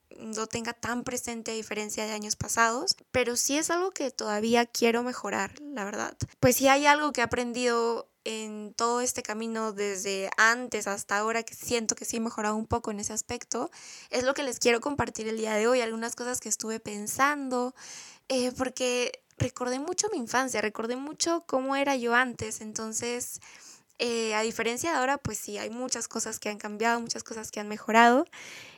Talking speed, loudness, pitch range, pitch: 190 wpm, -28 LUFS, 220-250 Hz, 235 Hz